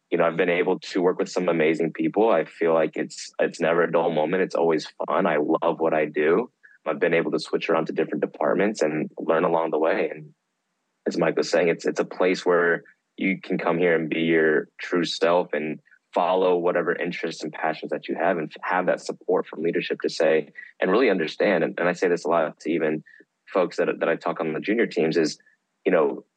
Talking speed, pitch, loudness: 235 wpm, 85 Hz, -24 LUFS